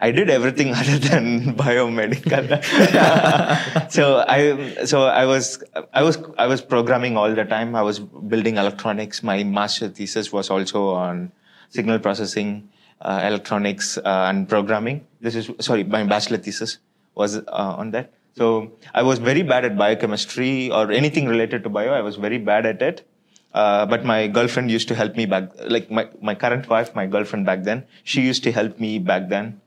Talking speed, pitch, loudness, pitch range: 180 wpm, 115 Hz, -20 LUFS, 105-125 Hz